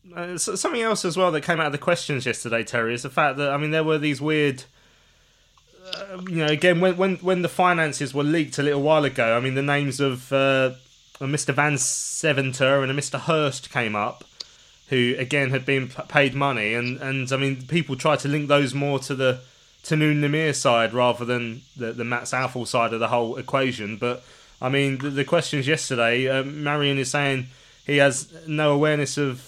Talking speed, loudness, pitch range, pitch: 210 wpm, -22 LUFS, 130-150 Hz, 140 Hz